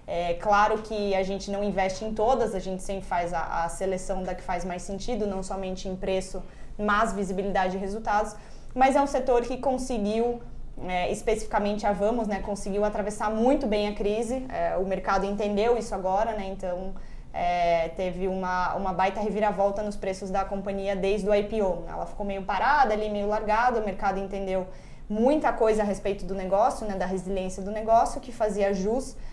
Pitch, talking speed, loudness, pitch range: 200 Hz, 190 wpm, -27 LUFS, 190-215 Hz